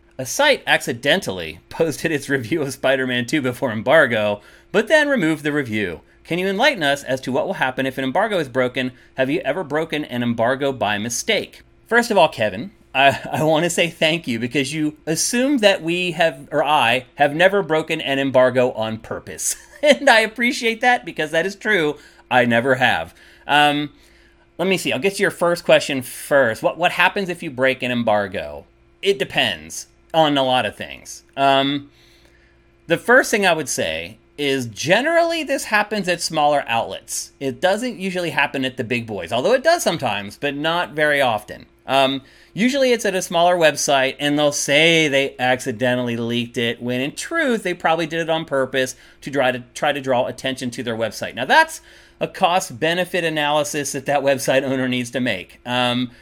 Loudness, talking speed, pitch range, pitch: -19 LUFS, 190 wpm, 125-175 Hz, 145 Hz